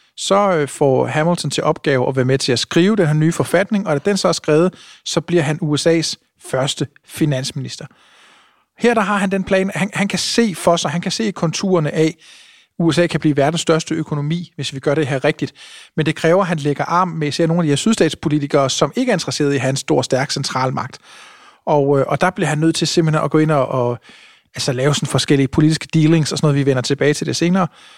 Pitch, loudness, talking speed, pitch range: 160 Hz, -17 LUFS, 230 wpm, 145-185 Hz